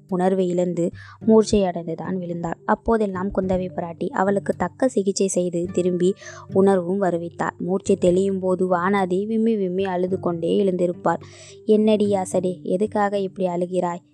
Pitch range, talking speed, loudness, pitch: 180-200 Hz, 120 wpm, -22 LUFS, 185 Hz